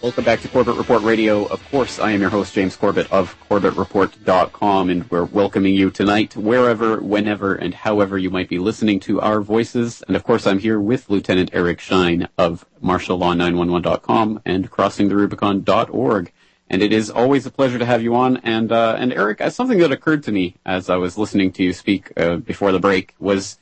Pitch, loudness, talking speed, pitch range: 100 Hz, -18 LUFS, 195 wpm, 95-115 Hz